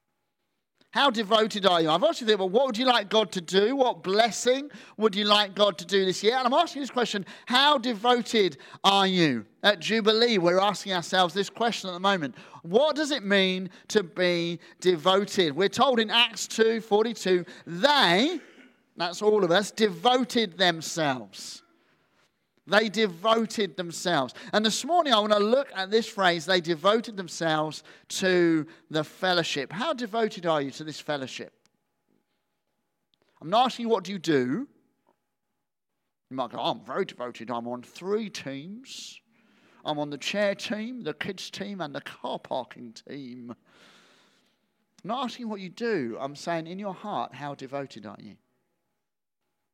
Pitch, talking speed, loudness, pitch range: 200 Hz, 165 wpm, -25 LUFS, 175-230 Hz